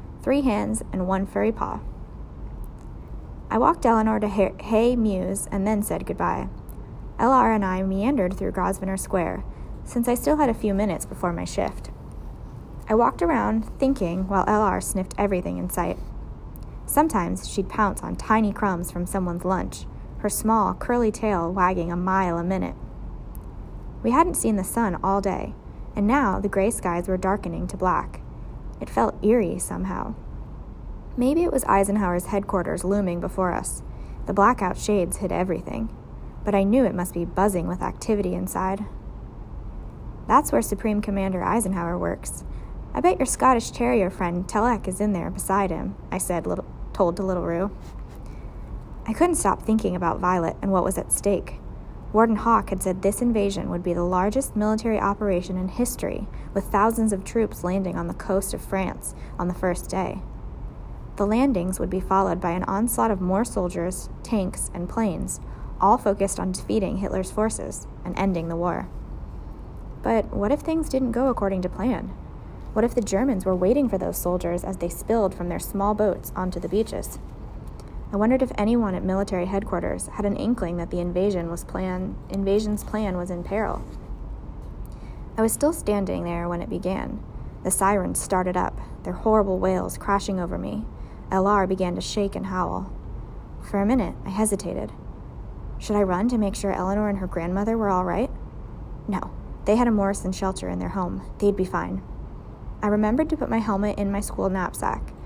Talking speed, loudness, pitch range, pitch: 175 wpm, -24 LUFS, 180-215 Hz, 195 Hz